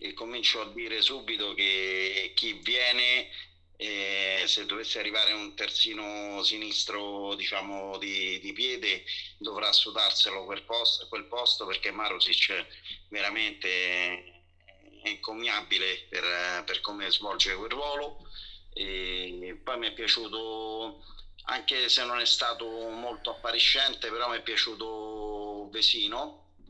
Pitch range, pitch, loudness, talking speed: 95-115 Hz, 105 Hz, -27 LUFS, 115 wpm